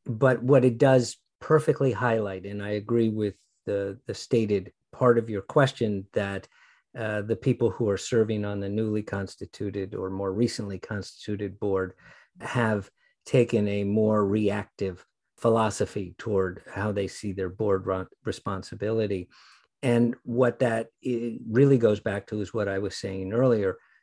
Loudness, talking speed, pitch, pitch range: -27 LUFS, 150 wpm, 105 Hz, 100-120 Hz